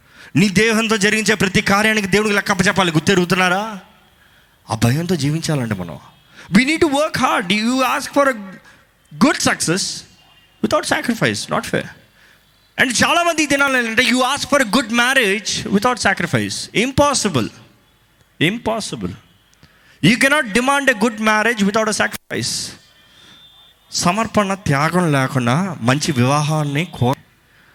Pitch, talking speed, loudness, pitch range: 205 Hz, 120 wpm, -16 LUFS, 170-240 Hz